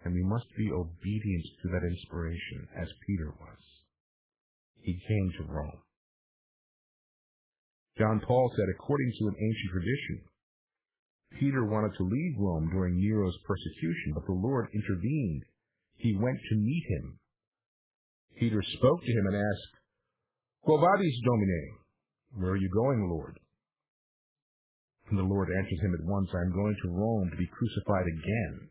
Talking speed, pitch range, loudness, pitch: 145 wpm, 90-110 Hz, -31 LUFS, 100 Hz